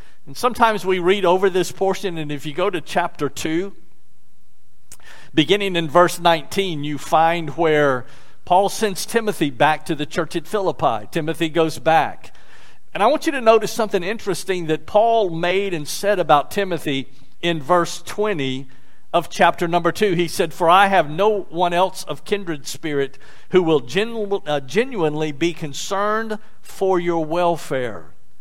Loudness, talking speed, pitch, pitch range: -20 LUFS, 160 wpm, 170 Hz, 150-195 Hz